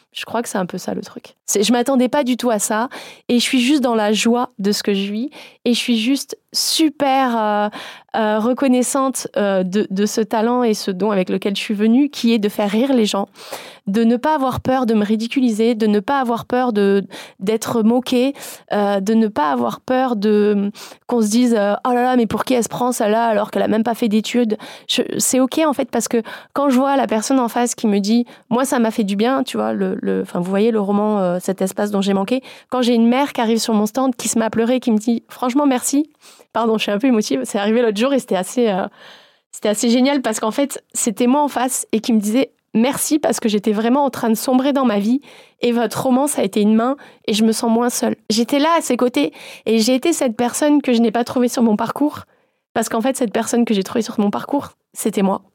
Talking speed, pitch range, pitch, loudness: 260 wpm, 215-255 Hz, 235 Hz, -18 LUFS